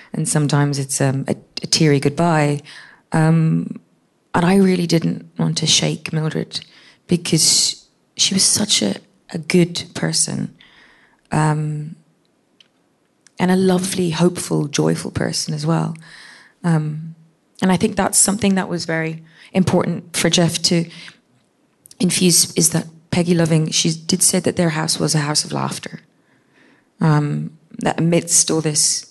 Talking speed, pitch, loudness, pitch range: 140 wpm, 165 Hz, -17 LUFS, 155-180 Hz